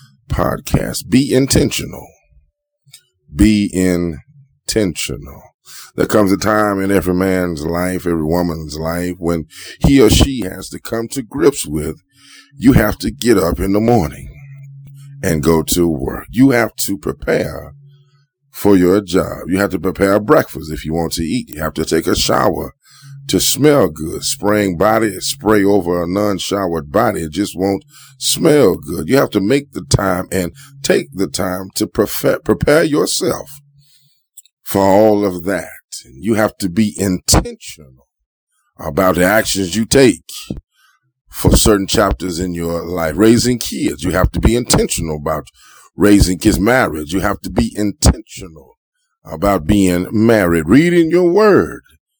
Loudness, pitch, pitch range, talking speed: -15 LUFS, 100 Hz, 85-120 Hz, 155 wpm